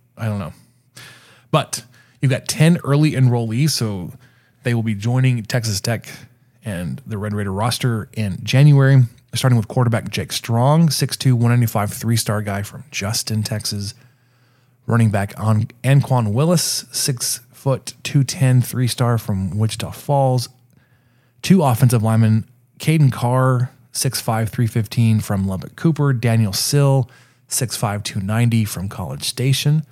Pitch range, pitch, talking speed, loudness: 110-130 Hz, 120 Hz, 130 wpm, -18 LUFS